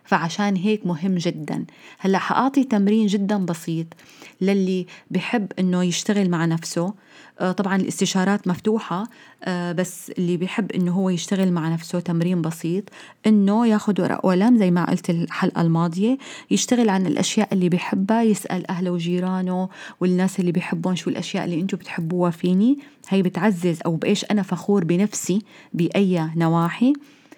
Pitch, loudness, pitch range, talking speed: 185 Hz, -22 LUFS, 175-210 Hz, 140 wpm